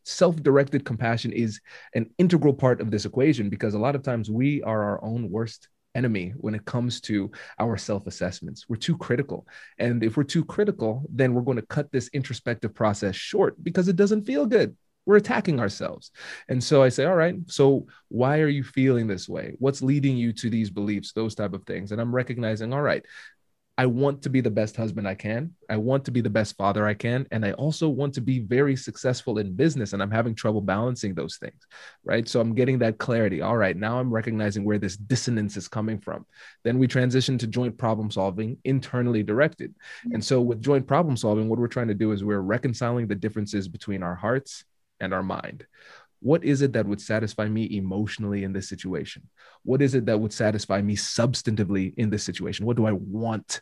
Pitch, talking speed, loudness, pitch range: 115 Hz, 215 wpm, -25 LUFS, 105-130 Hz